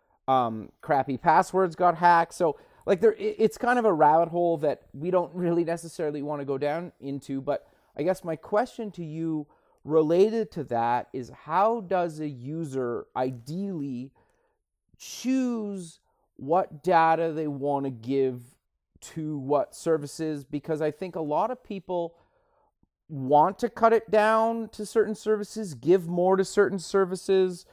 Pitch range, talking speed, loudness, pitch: 145-195 Hz, 150 wpm, -26 LUFS, 170 Hz